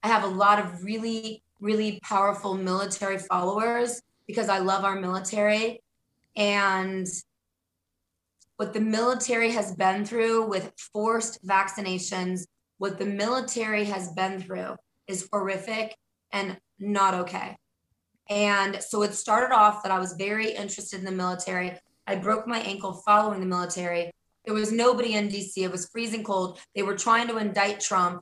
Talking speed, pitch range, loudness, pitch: 150 wpm, 190-215 Hz, -26 LUFS, 200 Hz